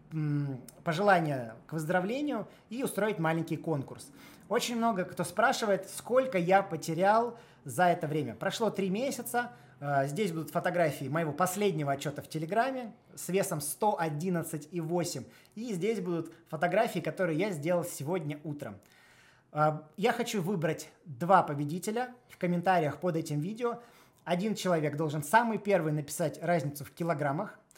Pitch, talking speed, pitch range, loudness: 175 Hz, 125 wpm, 155-205 Hz, -31 LUFS